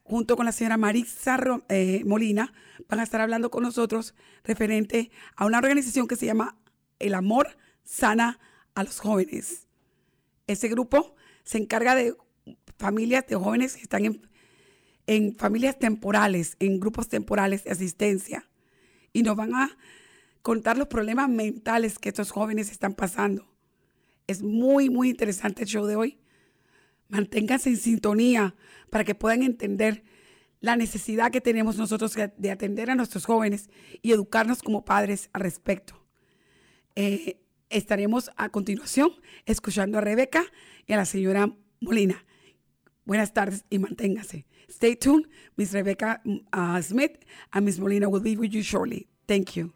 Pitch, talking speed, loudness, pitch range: 220 Hz, 145 wpm, -26 LUFS, 205-235 Hz